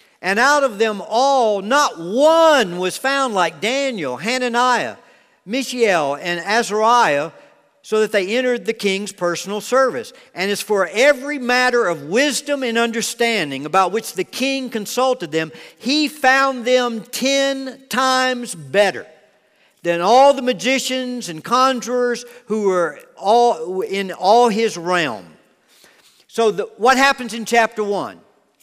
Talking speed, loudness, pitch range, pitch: 135 wpm, -17 LUFS, 200-260 Hz, 235 Hz